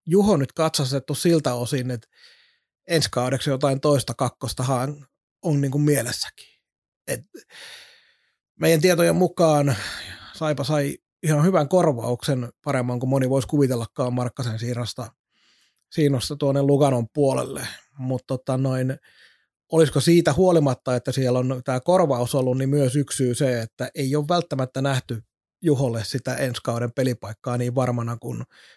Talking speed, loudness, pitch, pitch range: 130 wpm, -22 LUFS, 135 Hz, 125-150 Hz